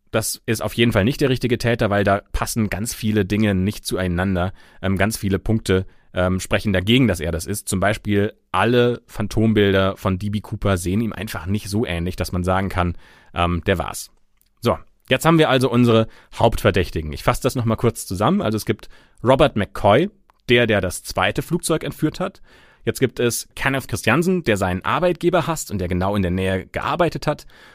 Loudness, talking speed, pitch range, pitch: -20 LUFS, 195 wpm, 95-120 Hz, 105 Hz